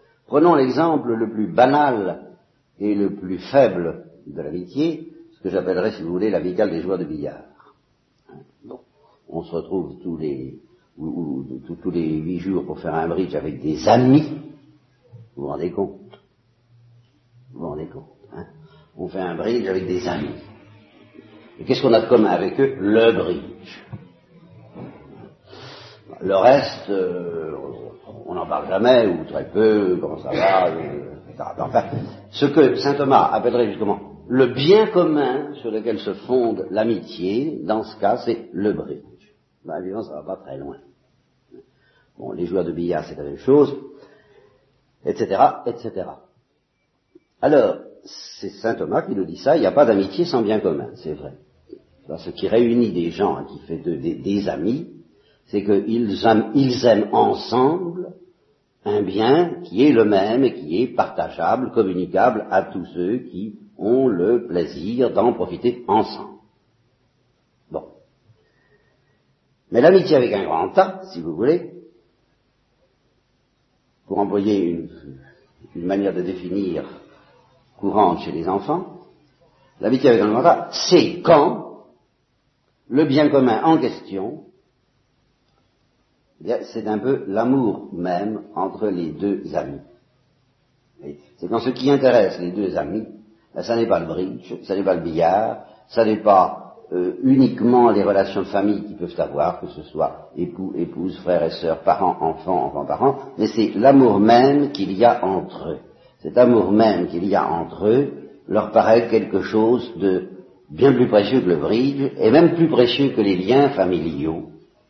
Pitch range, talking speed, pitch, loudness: 95-135 Hz, 160 wpm, 115 Hz, -19 LUFS